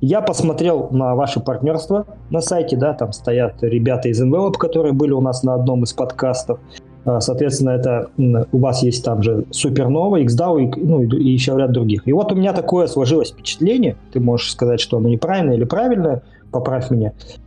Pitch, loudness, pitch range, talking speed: 130 Hz, -17 LUFS, 120-150 Hz, 180 wpm